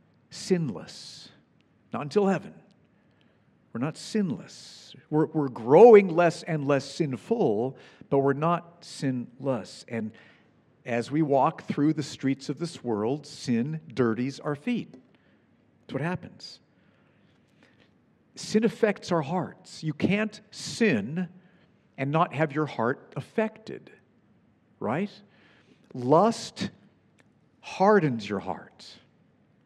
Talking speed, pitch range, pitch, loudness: 105 wpm, 135-190 Hz, 160 Hz, -26 LUFS